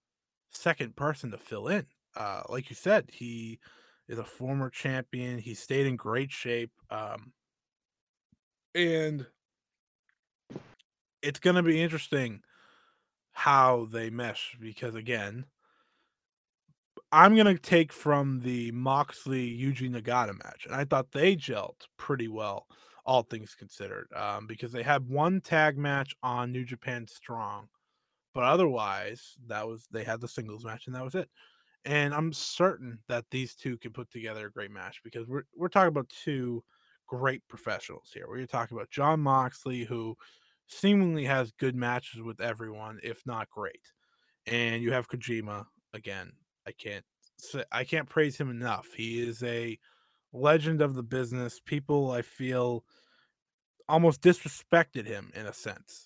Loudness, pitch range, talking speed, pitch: -30 LUFS, 120-145 Hz, 150 wpm, 125 Hz